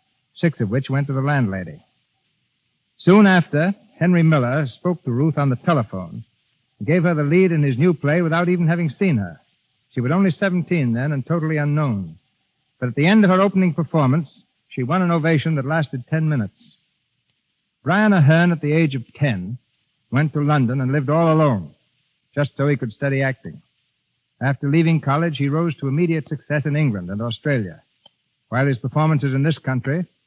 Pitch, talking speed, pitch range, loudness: 145 Hz, 185 wpm, 130-165 Hz, -19 LUFS